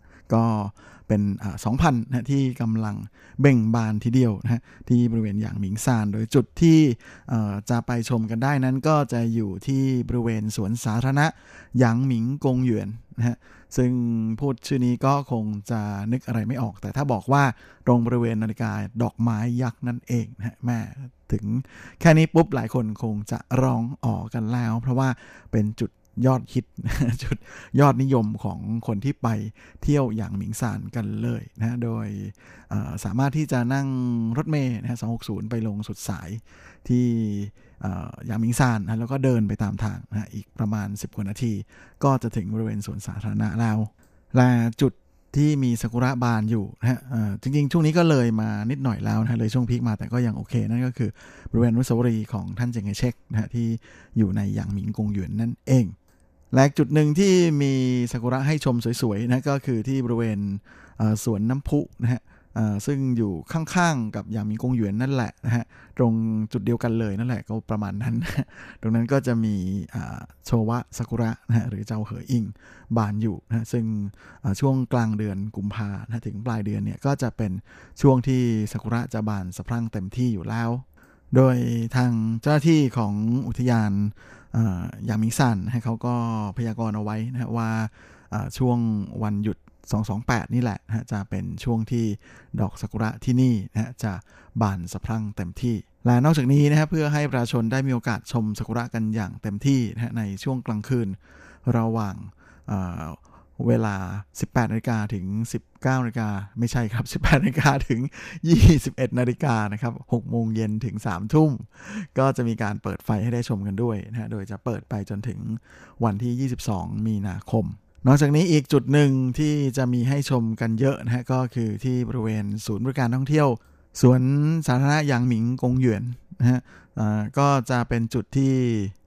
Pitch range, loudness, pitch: 110-125 Hz, -24 LUFS, 115 Hz